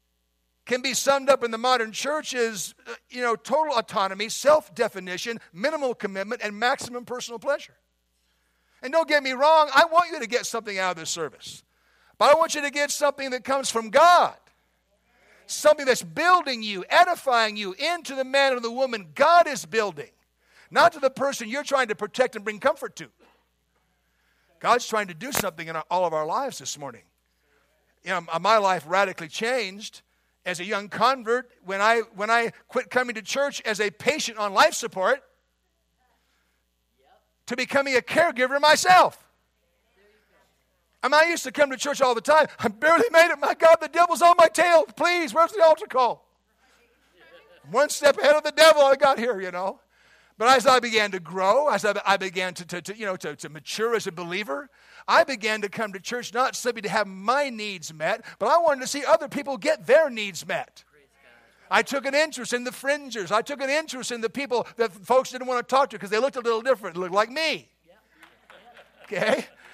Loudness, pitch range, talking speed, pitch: -23 LUFS, 200-285 Hz, 200 wpm, 245 Hz